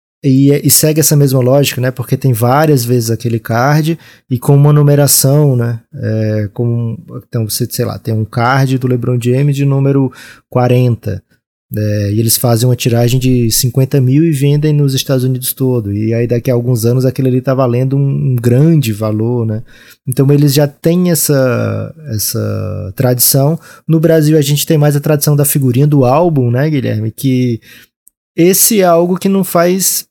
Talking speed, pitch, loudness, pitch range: 180 wpm, 130 Hz, -11 LUFS, 120-145 Hz